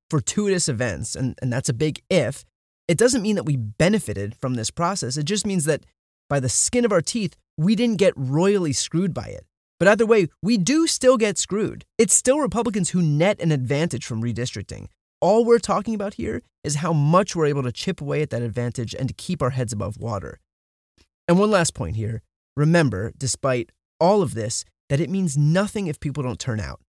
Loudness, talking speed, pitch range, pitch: -22 LUFS, 210 wpm, 120-195 Hz, 150 Hz